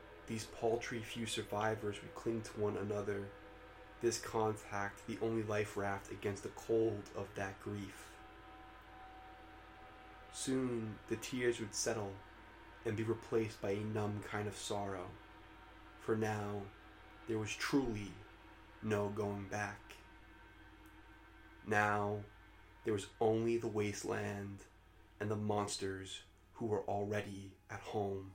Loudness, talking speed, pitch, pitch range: -40 LUFS, 120 wpm, 105 Hz, 100-110 Hz